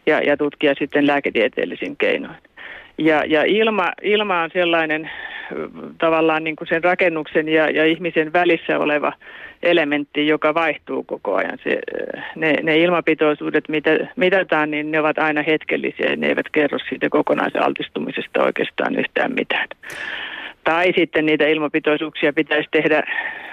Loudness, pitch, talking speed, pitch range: -19 LUFS, 160 Hz, 135 wpm, 155-175 Hz